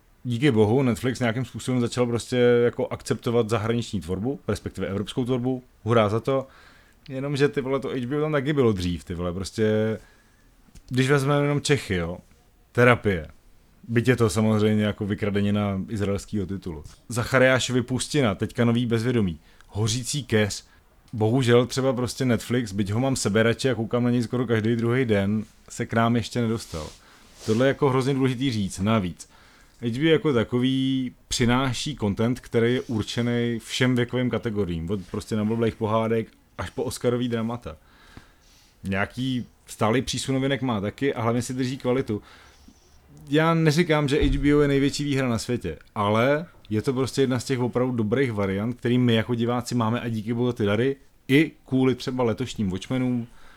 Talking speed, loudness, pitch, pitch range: 160 wpm, -24 LUFS, 120 Hz, 105-130 Hz